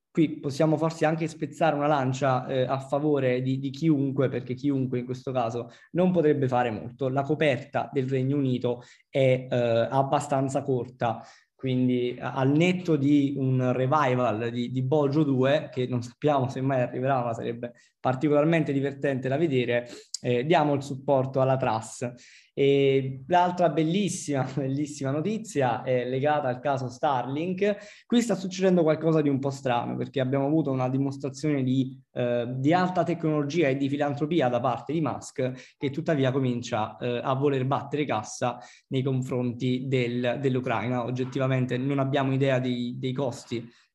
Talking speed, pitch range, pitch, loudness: 155 wpm, 125-150 Hz, 135 Hz, -26 LUFS